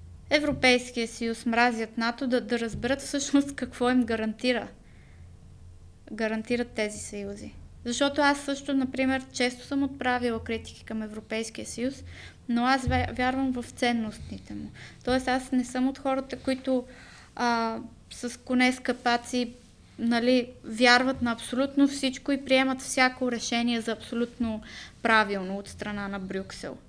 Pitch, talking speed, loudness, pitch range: 245 Hz, 130 wpm, -27 LUFS, 225-260 Hz